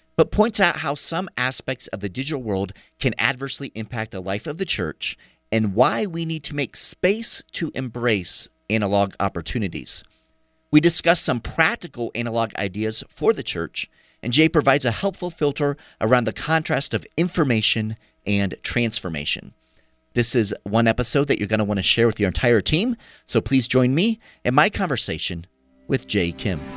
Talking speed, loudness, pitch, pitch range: 170 wpm, -21 LUFS, 125 Hz, 105-160 Hz